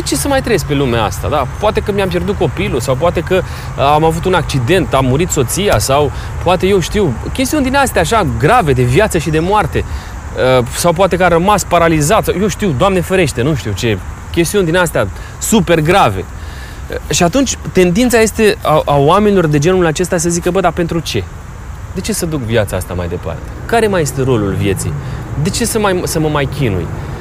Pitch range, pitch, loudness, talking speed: 120-185 Hz, 160 Hz, -13 LUFS, 205 wpm